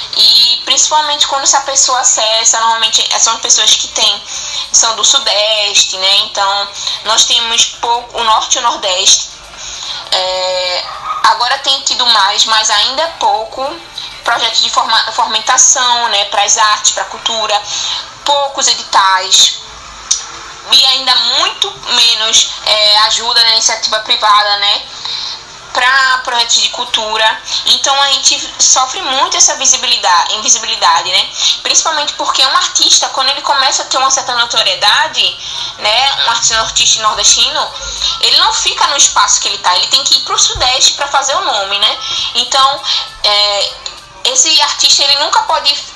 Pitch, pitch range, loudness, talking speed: 245 Hz, 220-280 Hz, -9 LUFS, 150 wpm